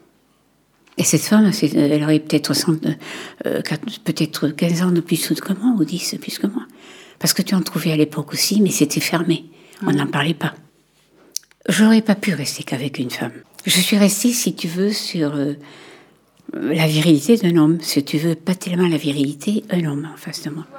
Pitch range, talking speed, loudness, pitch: 155-190 Hz, 190 wpm, -19 LUFS, 165 Hz